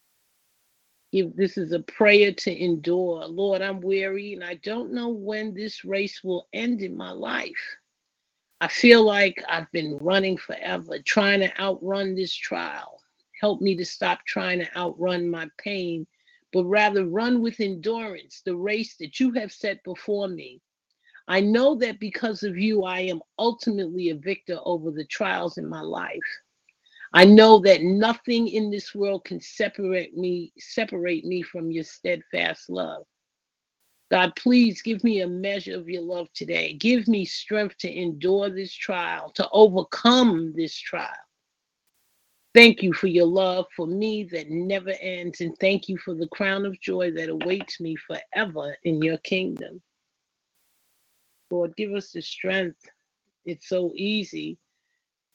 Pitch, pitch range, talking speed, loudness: 195 Hz, 175-215 Hz, 155 wpm, -23 LUFS